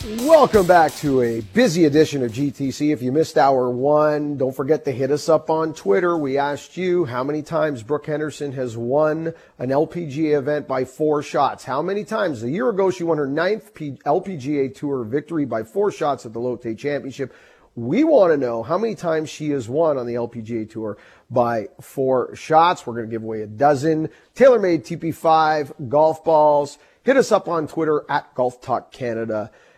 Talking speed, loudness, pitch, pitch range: 190 wpm, -20 LUFS, 150 Hz, 130-160 Hz